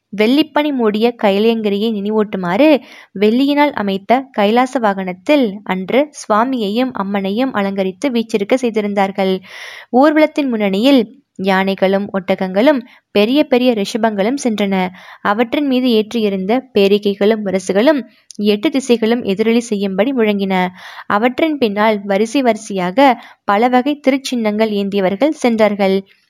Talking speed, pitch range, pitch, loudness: 95 wpm, 200-255 Hz, 220 Hz, -15 LUFS